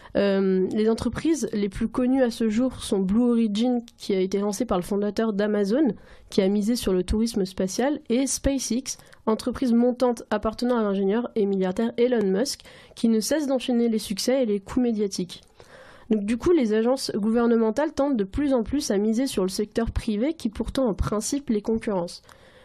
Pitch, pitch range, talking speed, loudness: 225 Hz, 210-250 Hz, 190 wpm, -24 LUFS